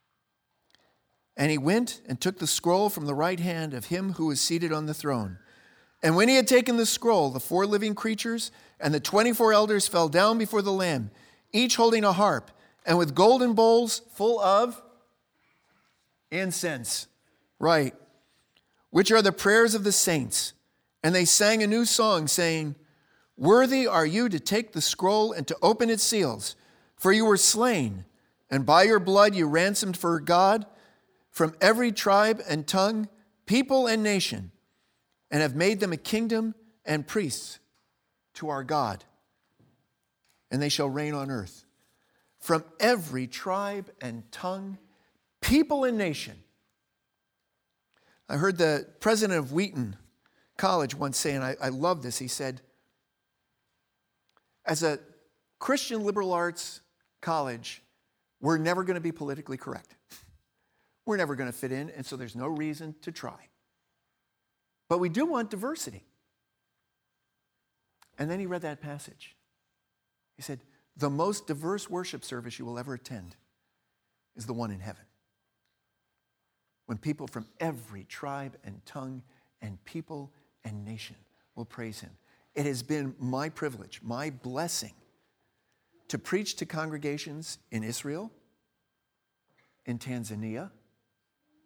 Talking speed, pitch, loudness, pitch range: 145 wpm, 160 Hz, -26 LUFS, 135-205 Hz